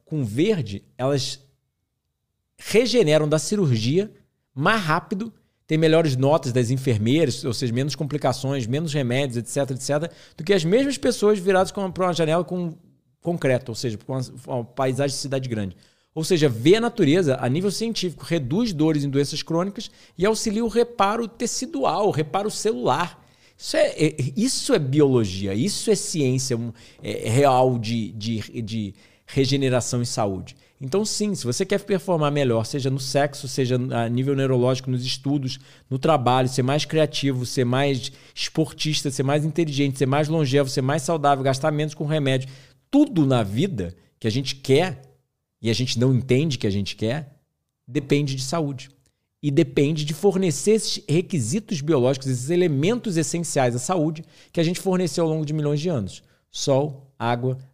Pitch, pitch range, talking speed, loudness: 145 Hz, 130-170 Hz, 165 wpm, -22 LUFS